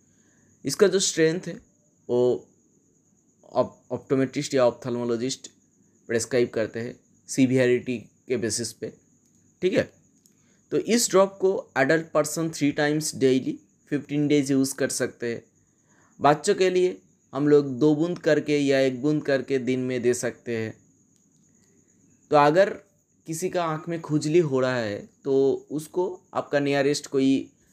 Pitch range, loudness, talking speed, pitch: 125-160 Hz, -24 LUFS, 140 wpm, 140 Hz